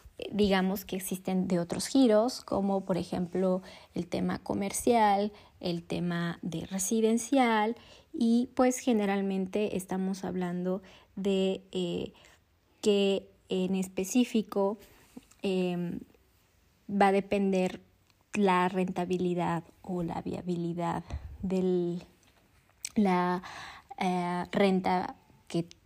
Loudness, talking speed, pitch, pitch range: -30 LUFS, 95 wpm, 190 Hz, 180-205 Hz